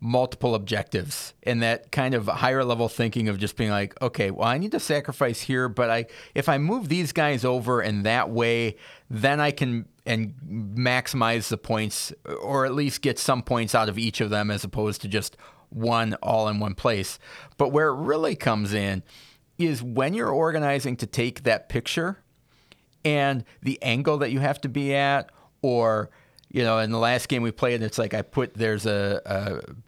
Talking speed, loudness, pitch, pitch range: 195 wpm, -25 LUFS, 120 Hz, 110-140 Hz